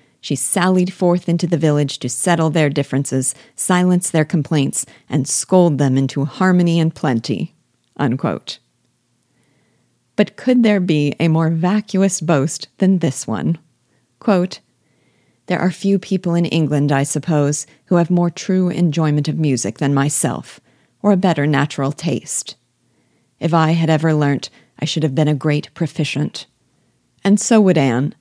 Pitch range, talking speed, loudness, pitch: 145-180 Hz, 150 wpm, -17 LUFS, 160 Hz